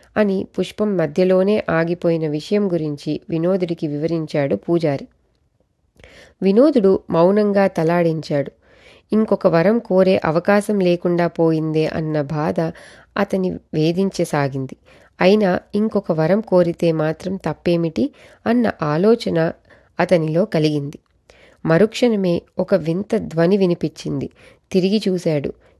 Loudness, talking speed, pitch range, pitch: -18 LUFS, 90 wpm, 160-200 Hz, 180 Hz